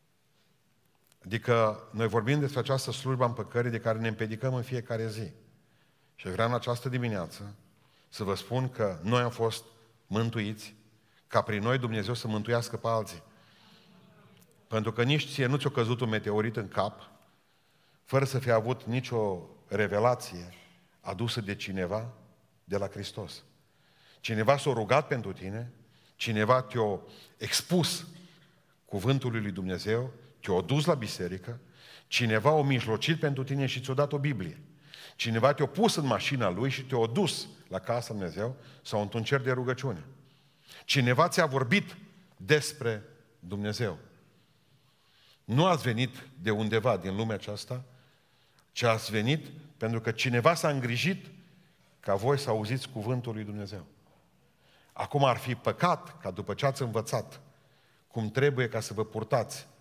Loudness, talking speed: -30 LUFS, 145 wpm